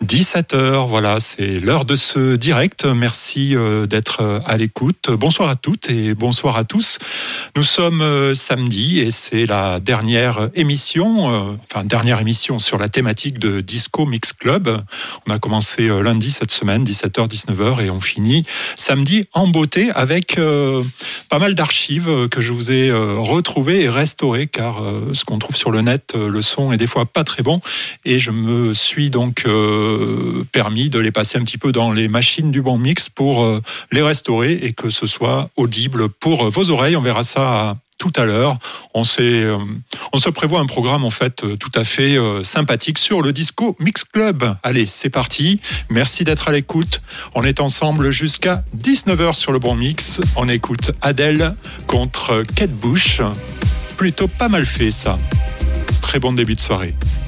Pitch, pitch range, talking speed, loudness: 125 Hz, 110-150 Hz, 180 wpm, -16 LUFS